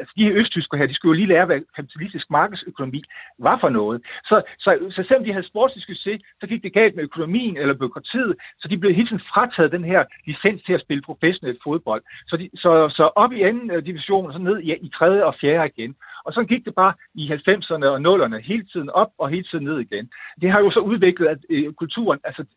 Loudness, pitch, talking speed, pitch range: -20 LUFS, 180 Hz, 235 wpm, 155-205 Hz